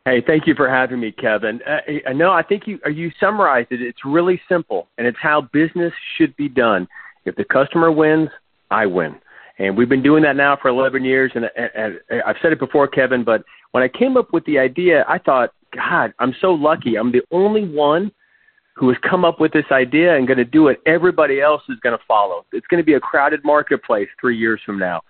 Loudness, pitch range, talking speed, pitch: -17 LUFS, 130-175 Hz, 230 wpm, 150 Hz